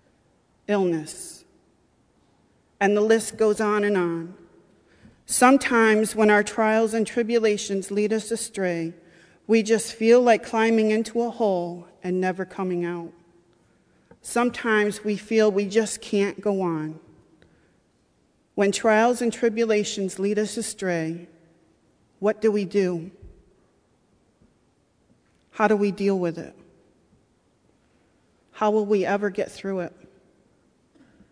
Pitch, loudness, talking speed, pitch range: 205 Hz, -23 LUFS, 115 wpm, 180-220 Hz